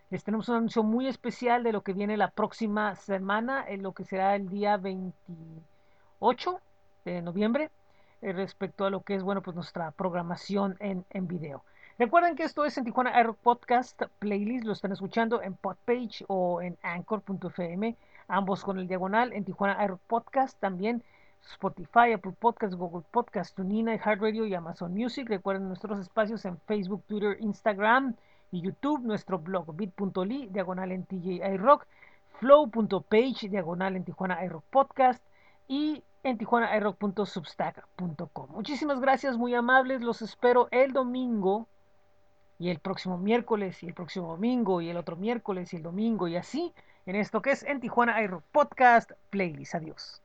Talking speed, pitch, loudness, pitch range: 155 wpm, 205 Hz, -29 LUFS, 185-235 Hz